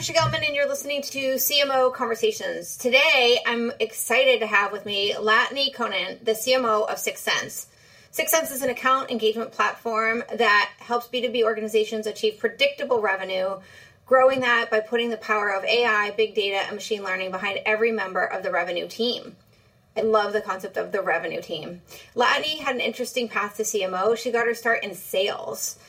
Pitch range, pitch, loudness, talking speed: 215-255 Hz, 230 Hz, -23 LUFS, 175 wpm